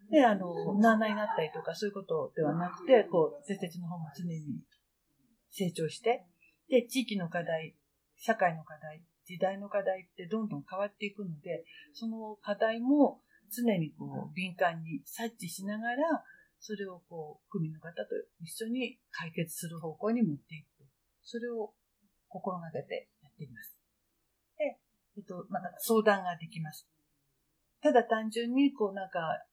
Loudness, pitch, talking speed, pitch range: -33 LUFS, 200 Hz, 295 characters per minute, 165-230 Hz